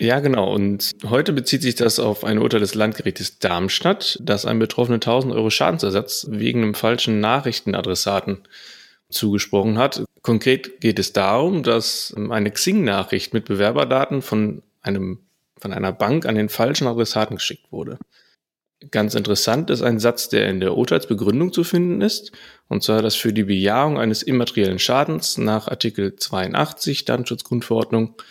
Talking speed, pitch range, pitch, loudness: 150 wpm, 105-125 Hz, 110 Hz, -20 LUFS